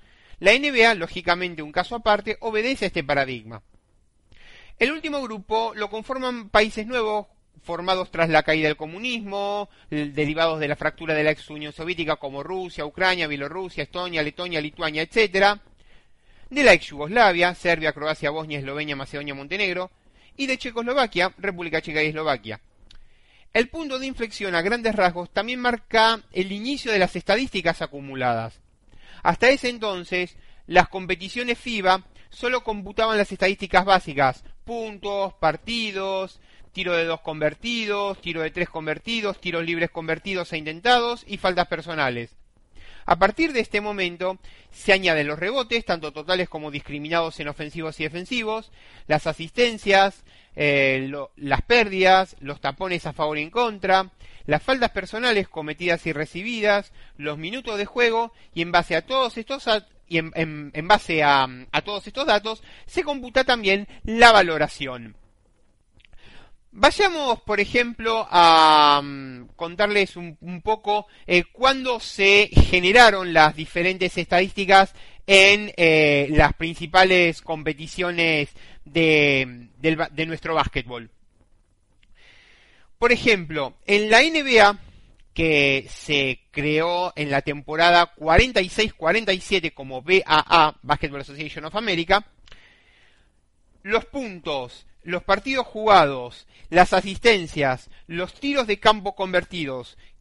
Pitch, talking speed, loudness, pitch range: 175 Hz, 125 wpm, -21 LUFS, 150-210 Hz